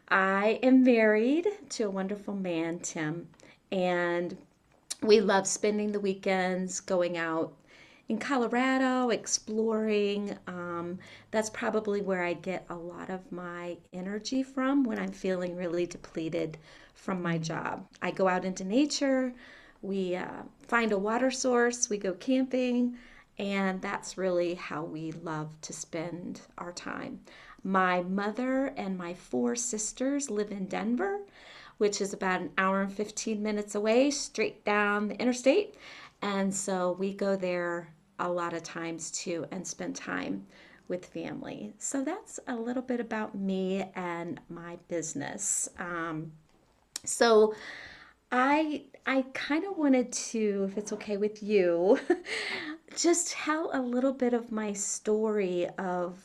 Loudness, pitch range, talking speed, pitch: -30 LUFS, 180-245 Hz, 140 wpm, 205 Hz